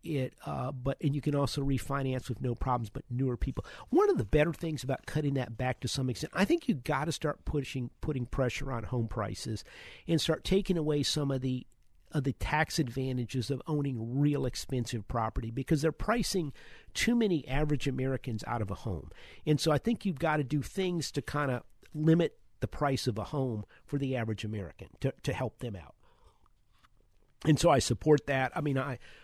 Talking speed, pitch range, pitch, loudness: 205 wpm, 125-155 Hz, 135 Hz, -32 LUFS